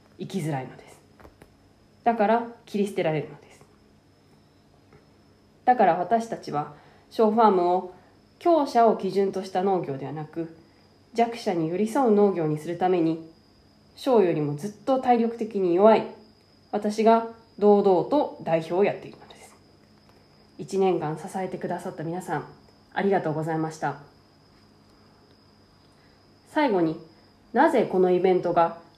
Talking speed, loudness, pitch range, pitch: 275 characters per minute, -24 LUFS, 165-215 Hz, 185 Hz